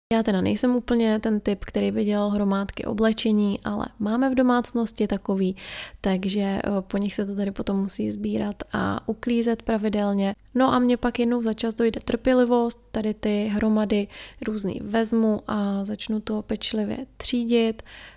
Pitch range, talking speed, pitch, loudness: 205-235 Hz, 155 wpm, 215 Hz, -24 LUFS